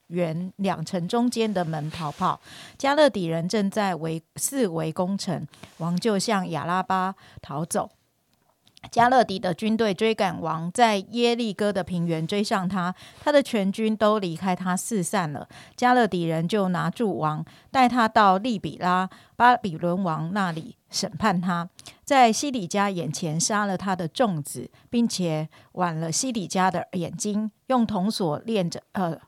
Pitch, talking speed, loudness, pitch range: 185 Hz, 225 characters per minute, -24 LUFS, 165-220 Hz